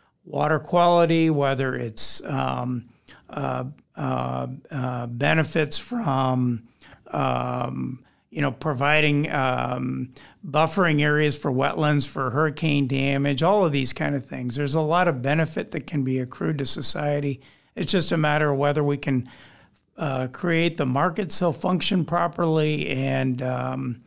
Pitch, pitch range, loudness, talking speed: 145 Hz, 130-160 Hz, -23 LUFS, 140 wpm